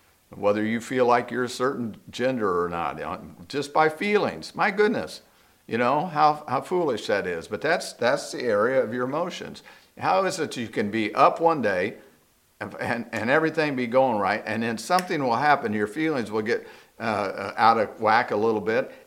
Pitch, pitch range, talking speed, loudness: 145 Hz, 115-185 Hz, 195 wpm, -24 LUFS